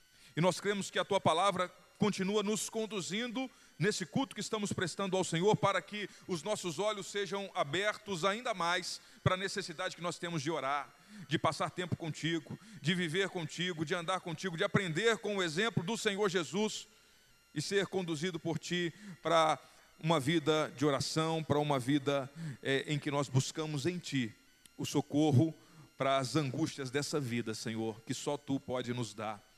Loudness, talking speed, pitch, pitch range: -35 LUFS, 170 wpm, 170 Hz, 150-195 Hz